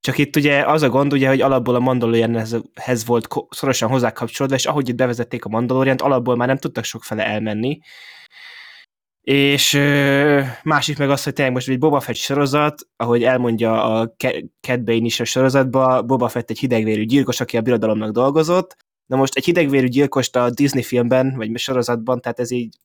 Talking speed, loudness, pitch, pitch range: 175 wpm, -18 LUFS, 130 Hz, 120-140 Hz